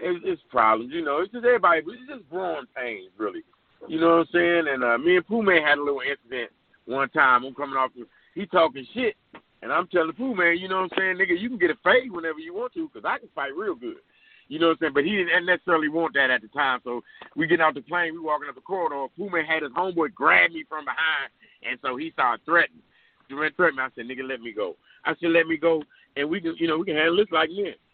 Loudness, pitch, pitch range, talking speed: -24 LUFS, 170 Hz, 150-240 Hz, 280 wpm